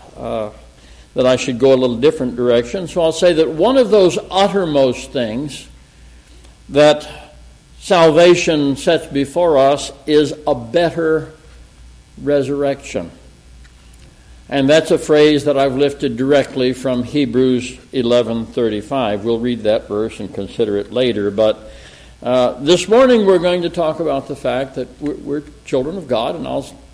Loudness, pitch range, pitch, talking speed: -15 LUFS, 115-150 Hz, 135 Hz, 145 wpm